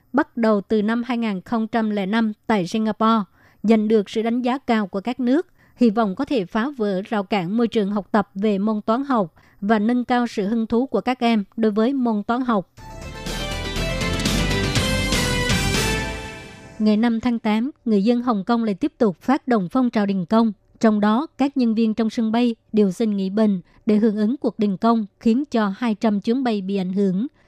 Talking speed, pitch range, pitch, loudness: 195 wpm, 210-235 Hz, 225 Hz, -21 LUFS